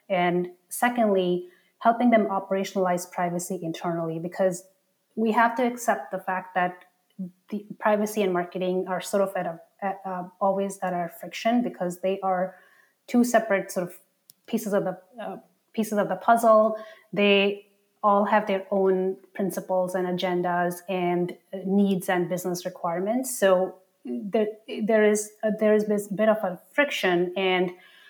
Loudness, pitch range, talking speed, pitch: -25 LUFS, 180-210 Hz, 150 wpm, 190 Hz